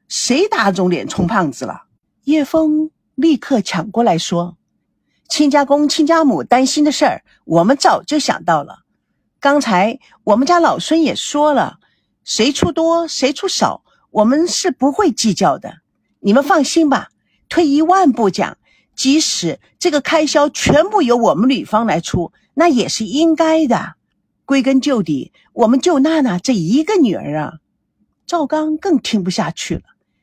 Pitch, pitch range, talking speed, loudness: 280 Hz, 220-315 Hz, 220 characters per minute, -15 LUFS